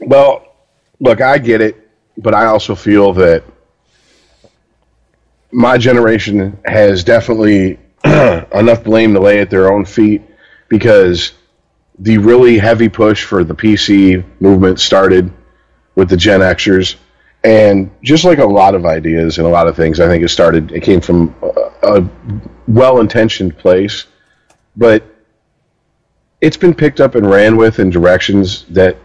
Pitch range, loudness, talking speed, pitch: 95-115 Hz, -9 LUFS, 145 wpm, 105 Hz